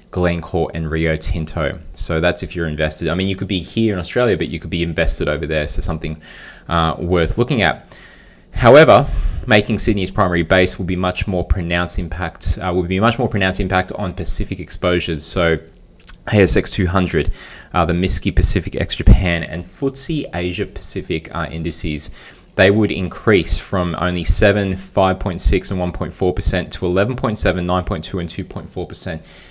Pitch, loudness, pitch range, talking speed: 90 Hz, -17 LUFS, 85-95 Hz, 165 wpm